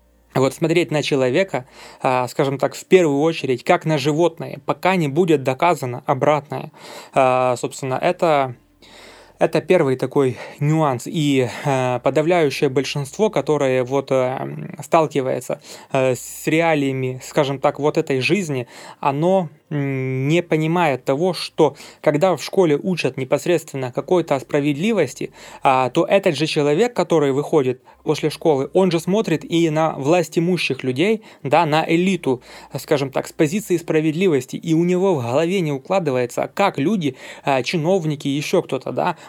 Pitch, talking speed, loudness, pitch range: 150 Hz, 140 wpm, -19 LUFS, 135-170 Hz